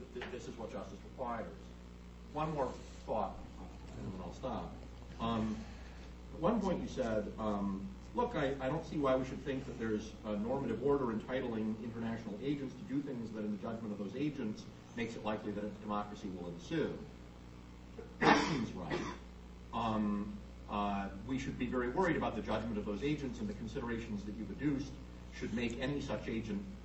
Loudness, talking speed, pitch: -39 LUFS, 180 wpm, 105 Hz